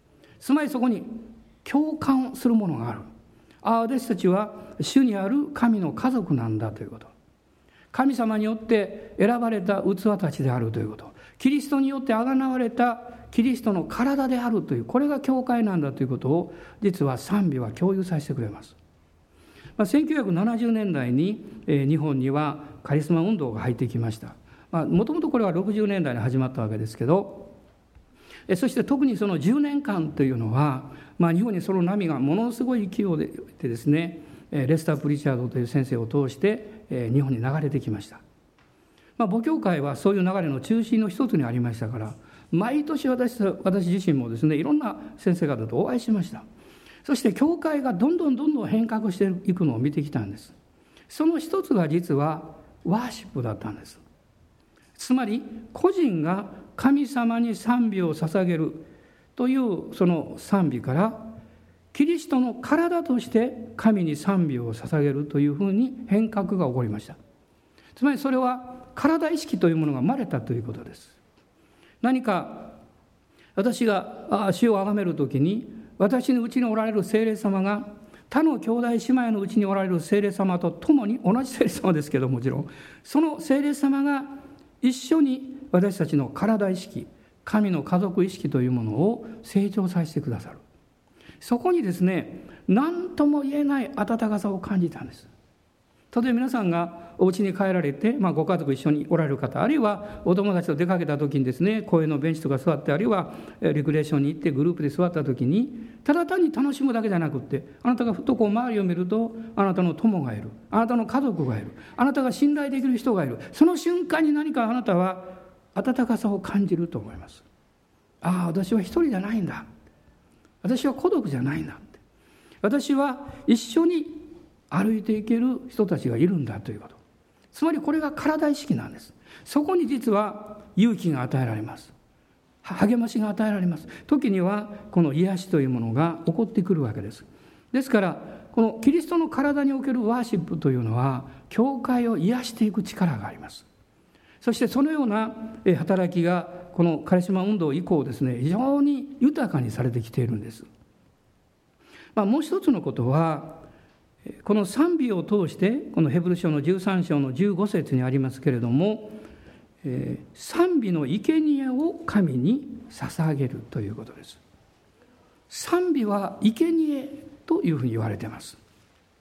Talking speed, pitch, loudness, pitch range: 325 characters per minute, 200 Hz, -24 LUFS, 150-245 Hz